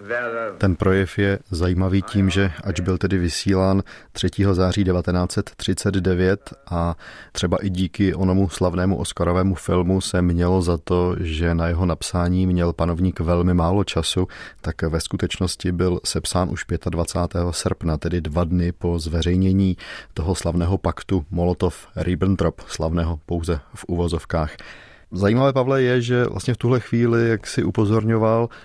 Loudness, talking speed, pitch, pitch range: -21 LUFS, 140 wpm, 90 Hz, 85-95 Hz